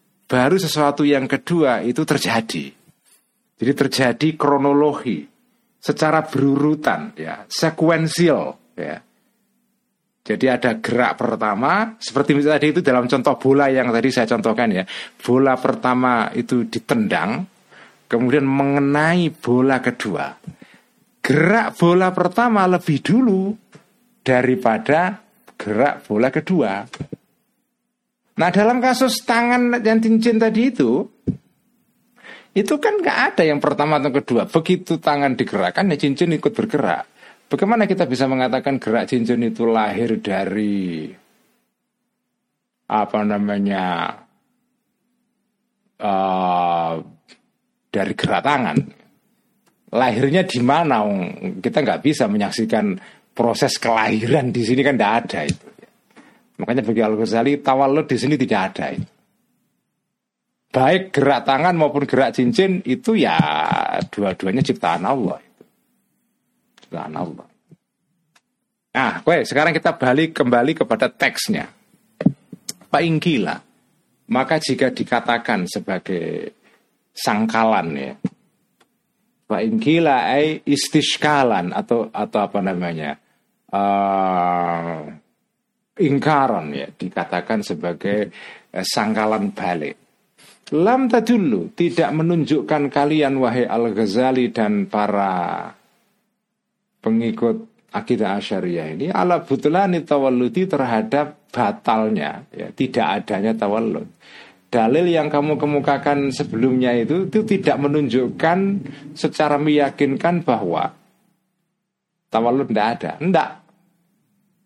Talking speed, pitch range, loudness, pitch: 100 wpm, 120-190 Hz, -19 LUFS, 145 Hz